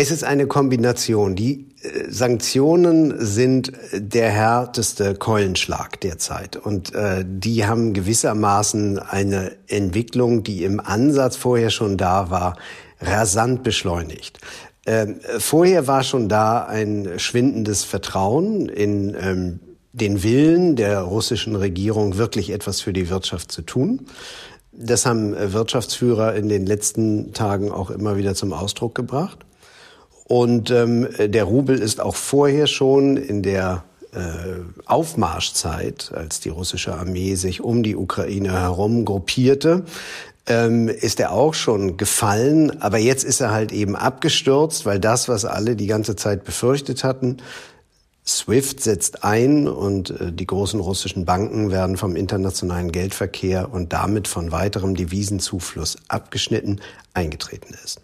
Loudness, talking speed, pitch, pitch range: -20 LUFS, 130 wpm, 105 Hz, 95-125 Hz